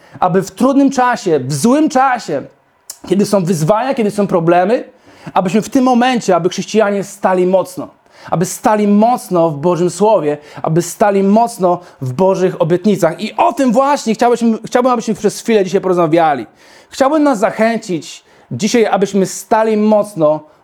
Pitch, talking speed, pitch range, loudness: 205 Hz, 150 wpm, 180-235 Hz, -13 LUFS